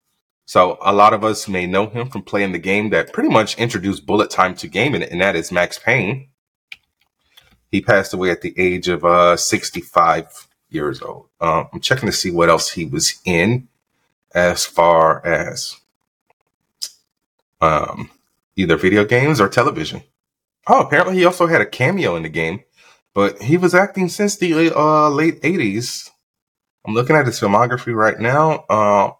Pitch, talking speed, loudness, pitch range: 110 Hz, 170 wpm, -16 LUFS, 95-150 Hz